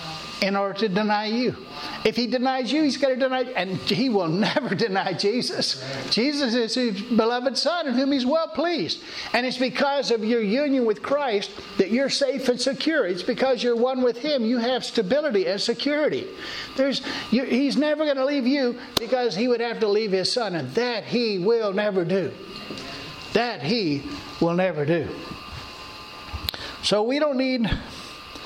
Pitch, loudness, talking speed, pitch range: 245 Hz, -23 LUFS, 180 wpm, 210-270 Hz